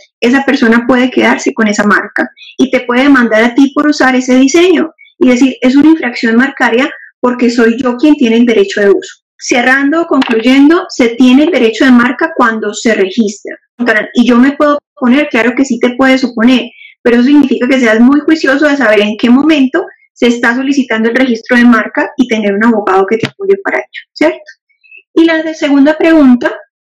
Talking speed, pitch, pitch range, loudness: 195 wpm, 260 Hz, 235-300 Hz, -8 LUFS